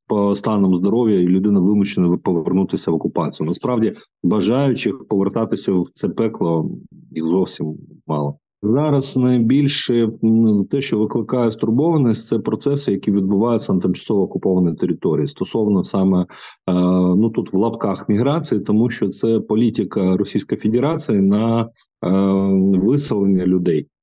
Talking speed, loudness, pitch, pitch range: 120 wpm, -18 LUFS, 100 Hz, 95-115 Hz